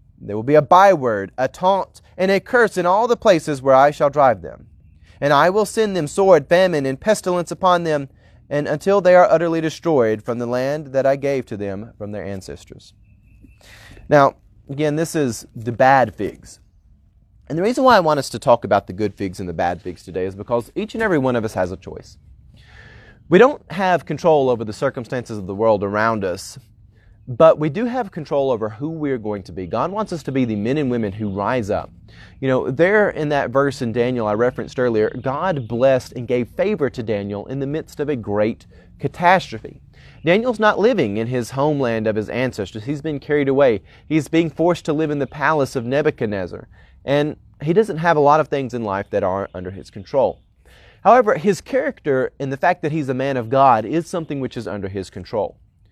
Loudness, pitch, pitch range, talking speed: -19 LUFS, 135 Hz, 105-155 Hz, 215 wpm